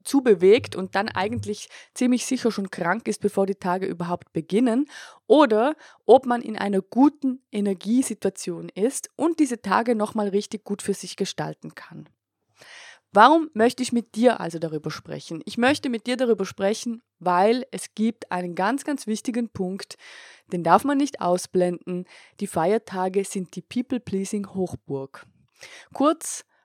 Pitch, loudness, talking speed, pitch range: 210 Hz, -23 LUFS, 155 wpm, 185-250 Hz